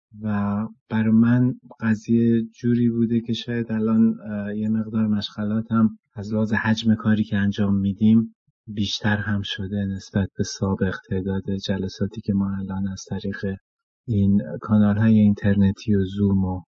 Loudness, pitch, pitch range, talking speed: -22 LUFS, 105 Hz, 100-110 Hz, 145 wpm